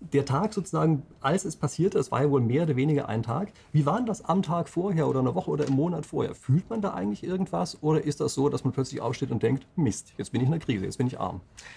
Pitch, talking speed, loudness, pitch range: 145 Hz, 275 wpm, -27 LUFS, 135-170 Hz